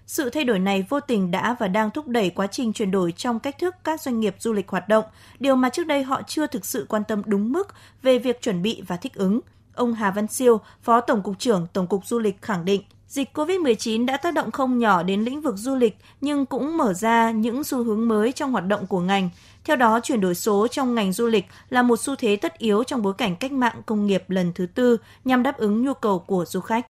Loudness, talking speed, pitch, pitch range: -23 LUFS, 260 wpm, 230 Hz, 205-260 Hz